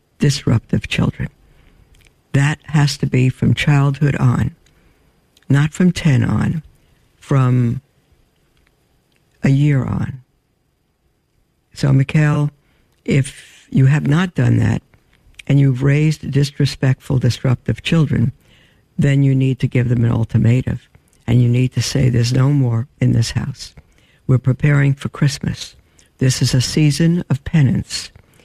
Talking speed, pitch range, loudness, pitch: 125 wpm, 120-145 Hz, -16 LUFS, 135 Hz